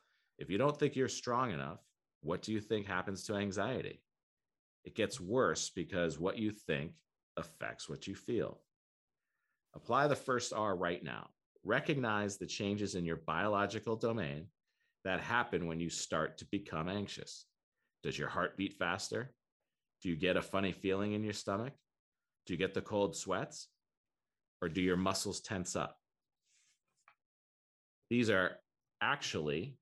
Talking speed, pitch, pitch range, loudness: 150 wpm, 100 Hz, 95-110 Hz, -37 LUFS